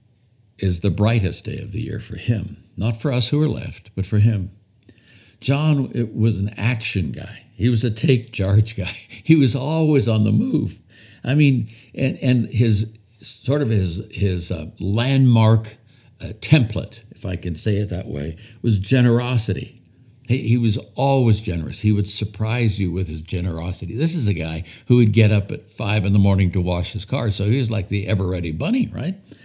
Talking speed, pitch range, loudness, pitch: 195 wpm, 100-120 Hz, -20 LUFS, 110 Hz